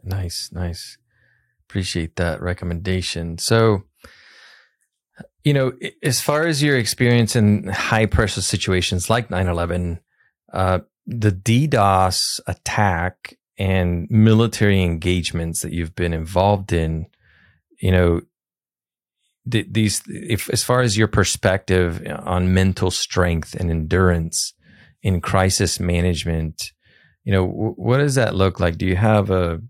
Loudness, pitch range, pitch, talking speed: -20 LUFS, 85-110 Hz, 95 Hz, 125 wpm